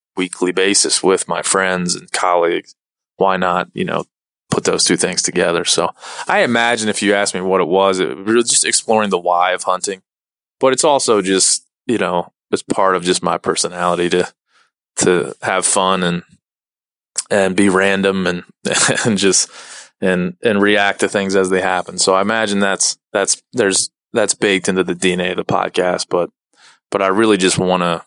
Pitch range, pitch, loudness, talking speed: 90-100 Hz, 95 Hz, -15 LUFS, 185 wpm